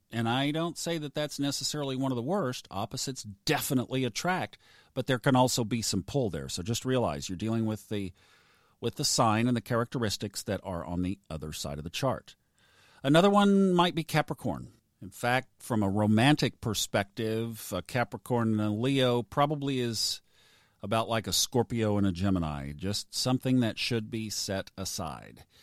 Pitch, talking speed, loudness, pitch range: 115 Hz, 180 wpm, -29 LUFS, 100-130 Hz